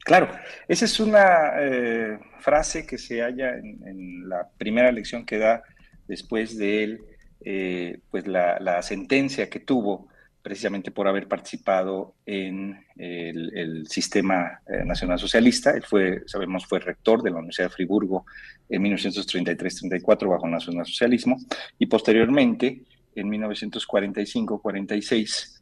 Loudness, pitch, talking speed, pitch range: -24 LUFS, 105 Hz, 130 wpm, 95-120 Hz